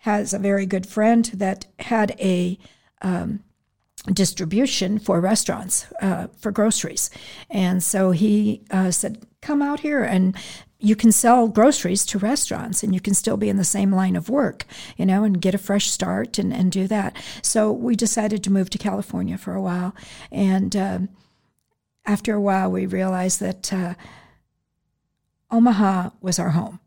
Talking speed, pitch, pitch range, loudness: 170 wpm, 200 Hz, 190-215 Hz, -21 LUFS